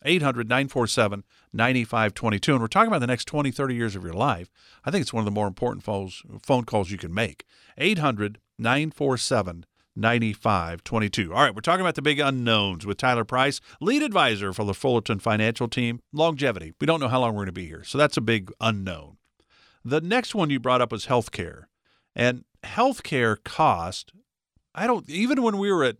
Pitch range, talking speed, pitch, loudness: 105-140 Hz, 185 wpm, 120 Hz, -24 LUFS